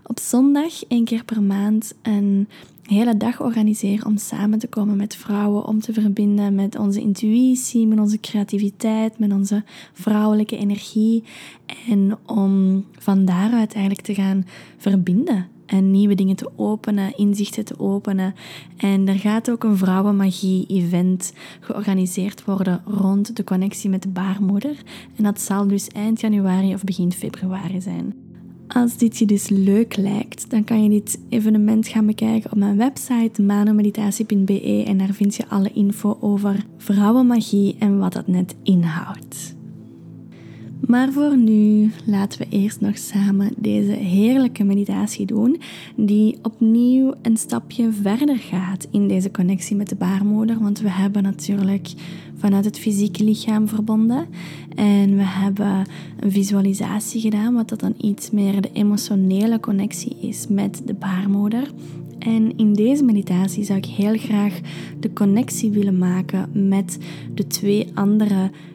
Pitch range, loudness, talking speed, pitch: 195-220 Hz, -19 LUFS, 145 wpm, 205 Hz